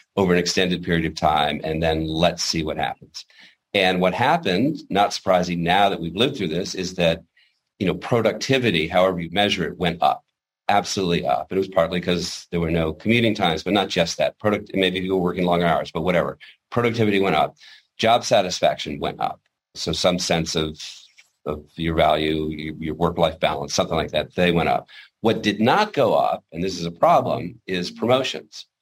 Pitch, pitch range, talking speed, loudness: 90 Hz, 80-95 Hz, 195 wpm, -21 LUFS